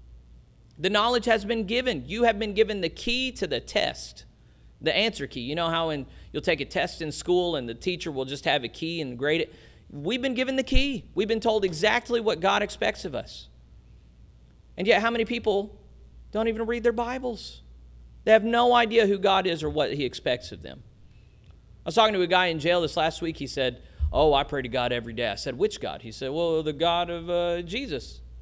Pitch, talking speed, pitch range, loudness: 175 Hz, 225 wpm, 140-225 Hz, -26 LUFS